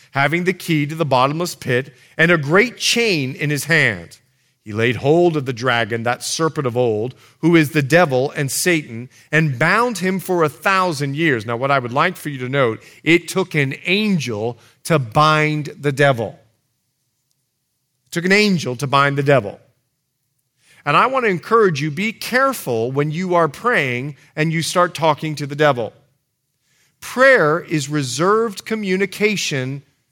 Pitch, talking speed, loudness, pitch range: 145 Hz, 170 wpm, -17 LUFS, 130-170 Hz